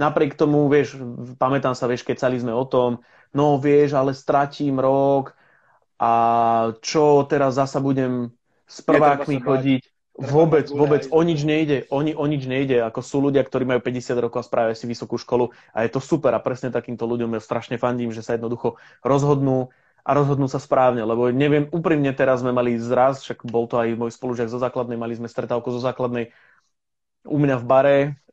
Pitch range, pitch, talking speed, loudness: 120-140 Hz, 130 Hz, 190 wpm, -21 LUFS